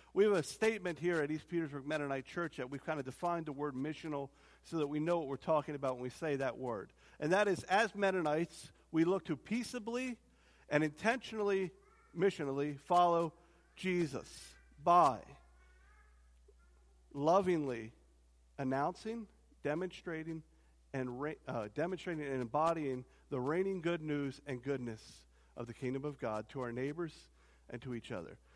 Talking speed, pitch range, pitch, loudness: 155 wpm, 125-175 Hz, 150 Hz, -37 LUFS